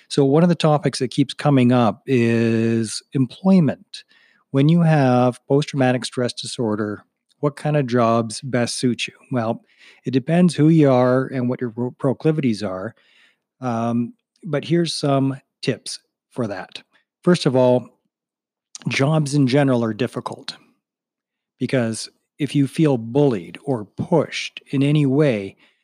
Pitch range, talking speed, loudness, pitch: 120-150 Hz, 140 wpm, -20 LUFS, 135 Hz